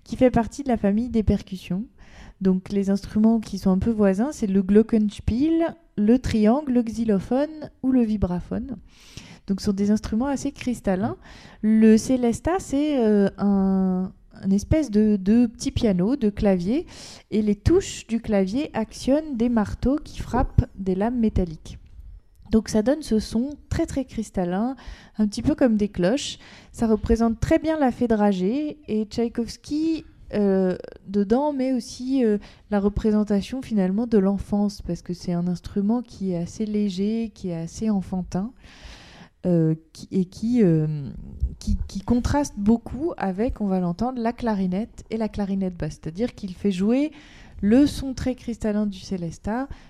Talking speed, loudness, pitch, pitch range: 160 wpm, -23 LUFS, 215 Hz, 195-240 Hz